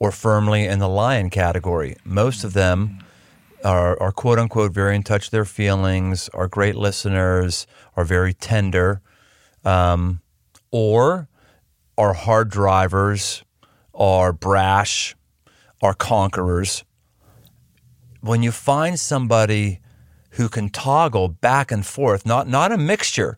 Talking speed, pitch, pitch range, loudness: 125 wpm, 100 Hz, 95-115 Hz, -19 LUFS